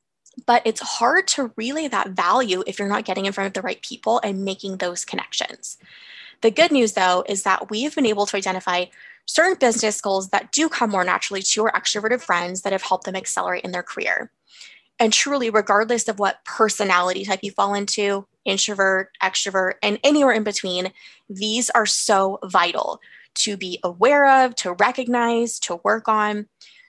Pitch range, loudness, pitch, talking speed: 195-235 Hz, -20 LUFS, 210 Hz, 180 wpm